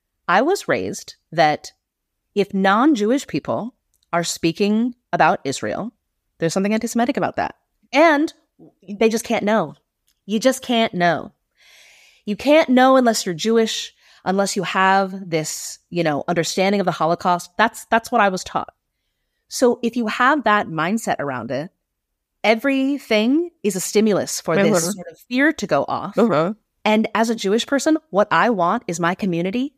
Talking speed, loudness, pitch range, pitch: 155 wpm, -19 LUFS, 180-240 Hz, 210 Hz